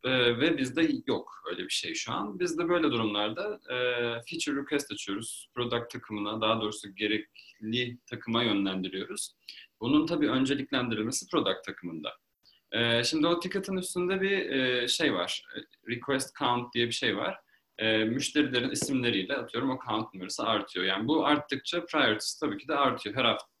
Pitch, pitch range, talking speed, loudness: 125 Hz, 110-155 Hz, 155 wpm, -30 LUFS